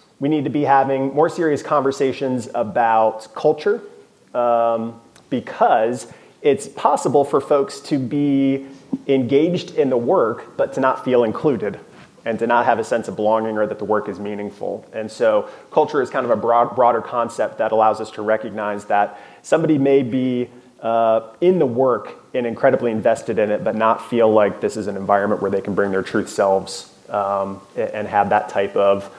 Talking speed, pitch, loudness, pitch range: 185 wpm, 115 Hz, -19 LUFS, 105-135 Hz